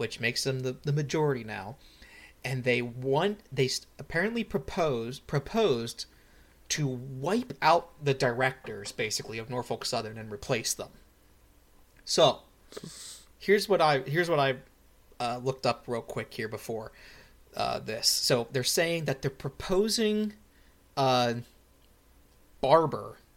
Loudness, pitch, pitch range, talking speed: -29 LUFS, 130 Hz, 115-155 Hz, 125 wpm